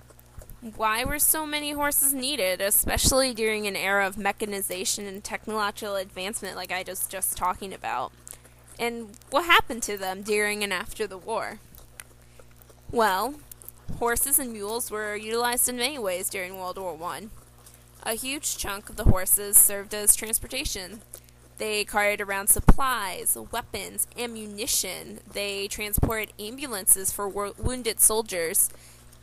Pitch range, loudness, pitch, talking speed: 185-225 Hz, -25 LUFS, 205 Hz, 135 wpm